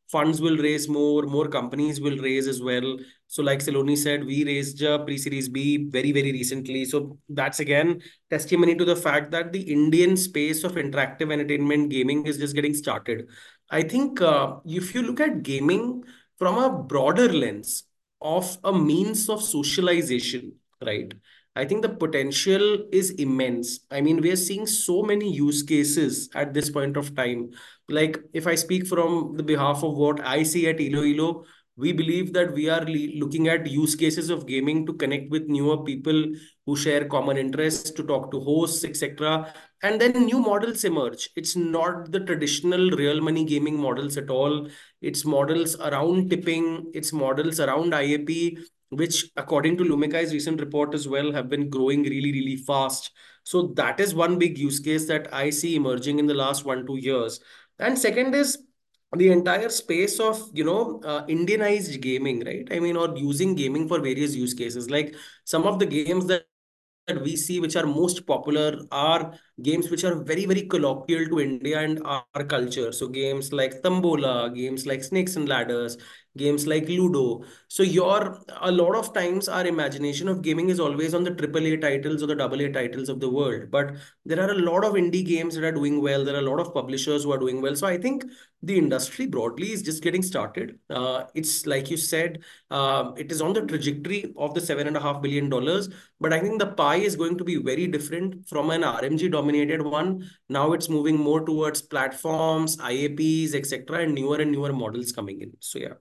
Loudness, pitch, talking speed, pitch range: -24 LUFS, 155 Hz, 190 wpm, 145-175 Hz